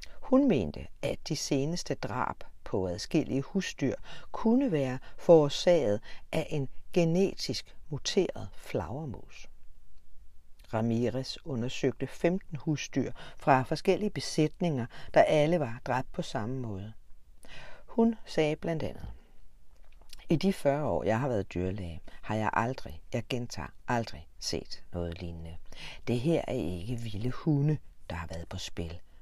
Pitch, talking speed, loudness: 125 Hz, 130 wpm, -31 LUFS